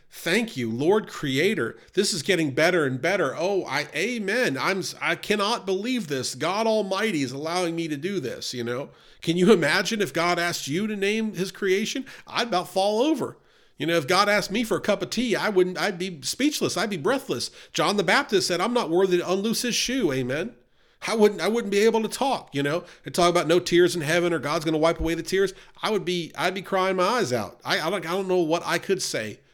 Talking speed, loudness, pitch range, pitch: 240 wpm, -24 LUFS, 170-210 Hz, 185 Hz